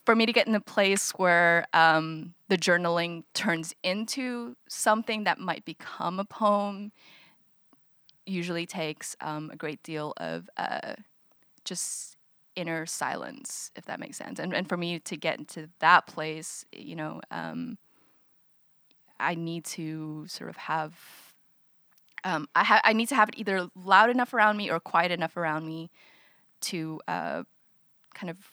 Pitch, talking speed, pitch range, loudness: 175 Hz, 155 wpm, 160-205 Hz, -28 LUFS